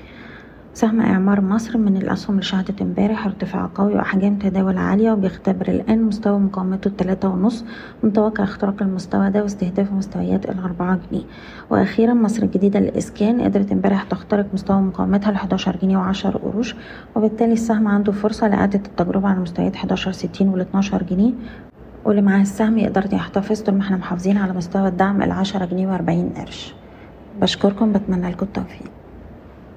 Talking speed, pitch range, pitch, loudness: 150 wpm, 190-210 Hz, 200 Hz, -19 LUFS